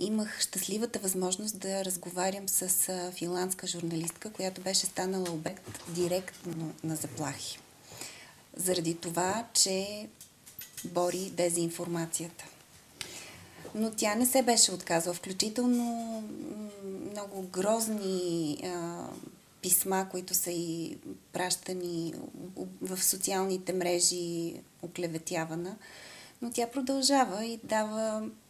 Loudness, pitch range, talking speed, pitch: -31 LUFS, 175-205 Hz, 95 wpm, 185 Hz